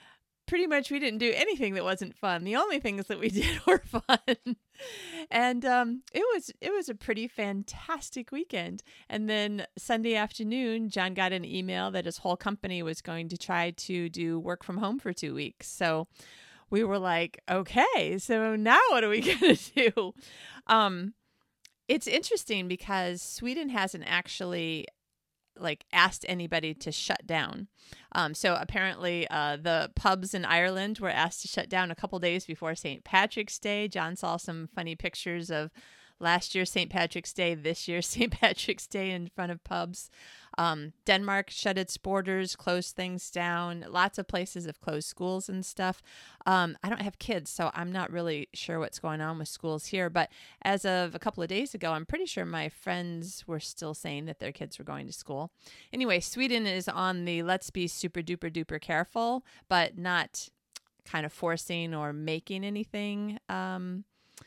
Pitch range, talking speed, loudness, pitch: 170-215 Hz, 180 wpm, -30 LUFS, 185 Hz